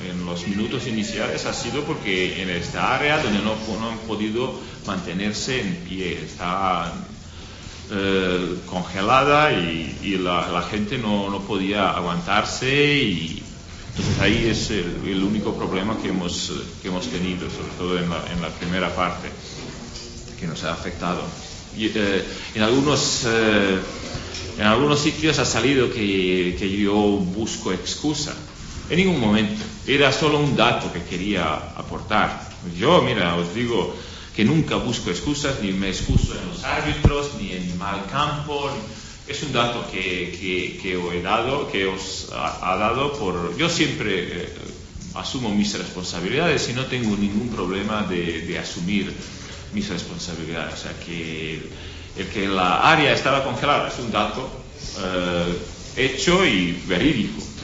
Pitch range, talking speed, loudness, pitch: 90-110 Hz, 150 wpm, -22 LUFS, 95 Hz